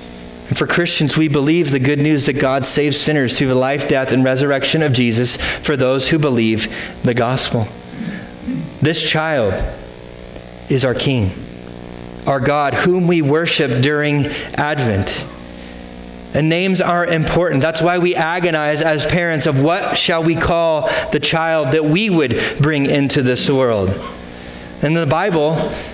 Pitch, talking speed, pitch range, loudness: 145 Hz, 150 wpm, 115-160 Hz, -16 LUFS